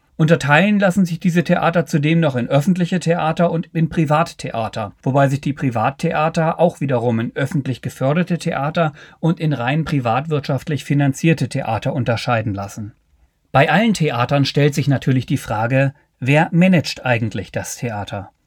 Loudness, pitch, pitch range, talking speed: -18 LUFS, 145 Hz, 130-165 Hz, 145 wpm